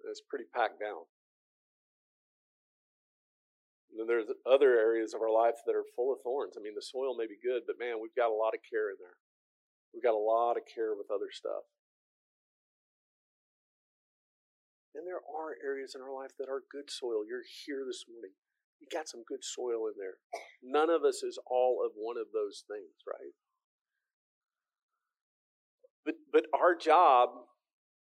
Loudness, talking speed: -33 LUFS, 170 wpm